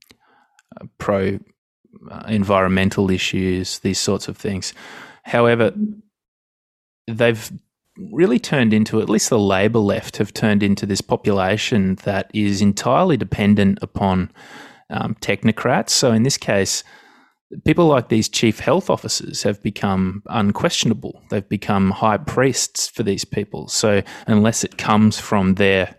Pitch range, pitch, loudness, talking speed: 100-115 Hz, 105 Hz, -18 LUFS, 130 wpm